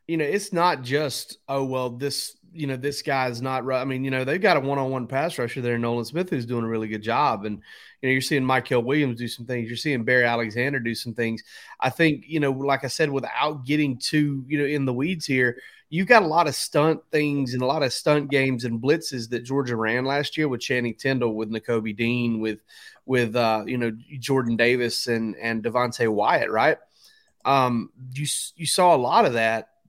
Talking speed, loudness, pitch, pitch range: 230 wpm, -24 LUFS, 130 Hz, 120-145 Hz